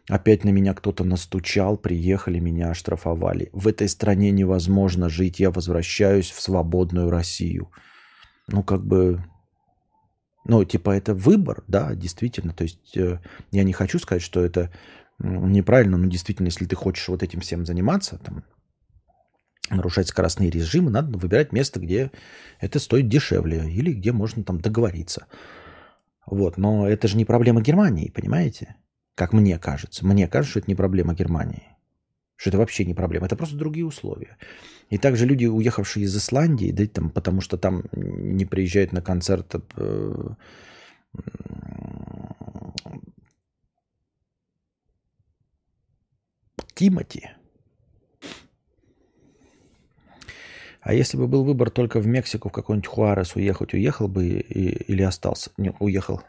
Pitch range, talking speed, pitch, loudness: 90-110 Hz, 130 wpm, 95 Hz, -22 LUFS